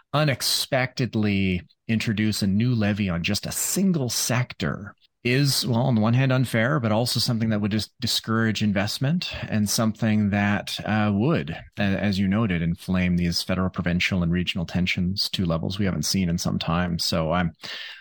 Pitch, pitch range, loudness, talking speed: 105 Hz, 90-115 Hz, -23 LUFS, 170 wpm